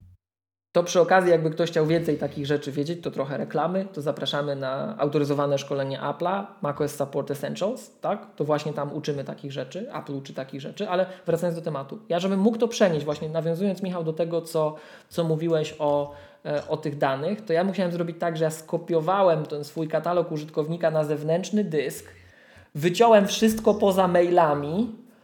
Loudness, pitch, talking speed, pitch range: -25 LUFS, 160 Hz, 175 wpm, 145-180 Hz